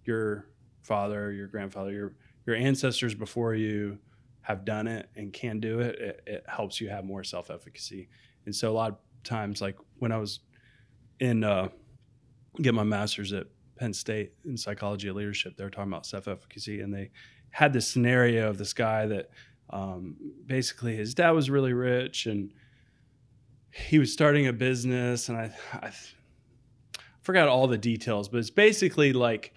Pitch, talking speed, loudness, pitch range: 115 Hz, 175 wpm, -29 LUFS, 105-125 Hz